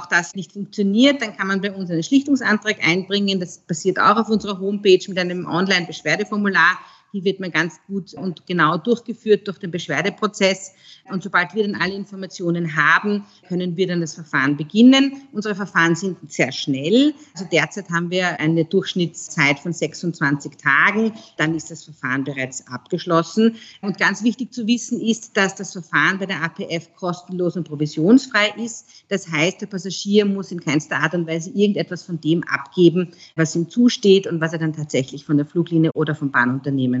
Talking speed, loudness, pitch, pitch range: 175 wpm, -19 LUFS, 180 Hz, 160-200 Hz